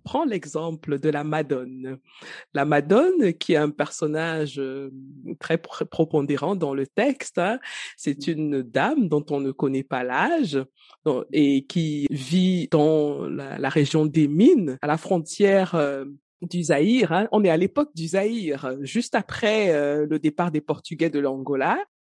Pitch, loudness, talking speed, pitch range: 155 Hz, -23 LUFS, 160 wpm, 140-180 Hz